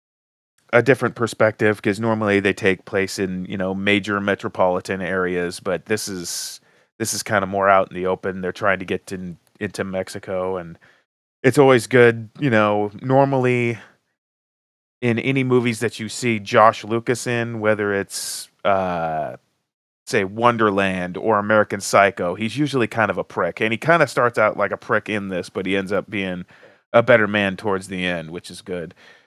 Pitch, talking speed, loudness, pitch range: 100 Hz, 180 wpm, -20 LUFS, 95-115 Hz